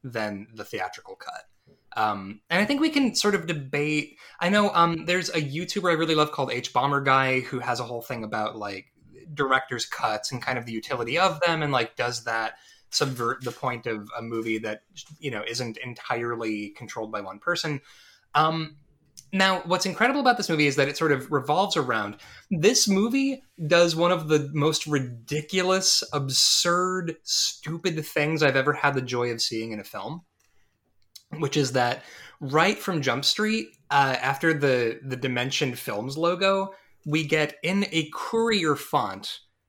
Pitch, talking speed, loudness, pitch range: 145 Hz, 175 wpm, -25 LUFS, 120-170 Hz